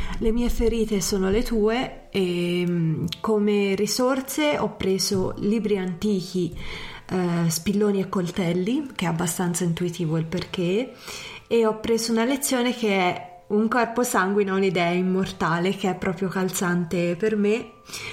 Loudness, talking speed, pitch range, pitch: -24 LUFS, 135 wpm, 180-220 Hz, 195 Hz